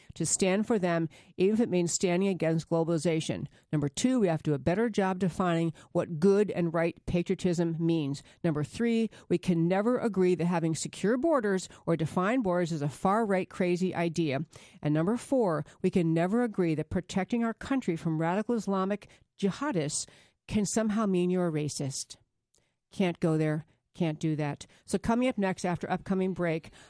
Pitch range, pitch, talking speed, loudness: 165-195 Hz, 175 Hz, 180 wpm, -29 LUFS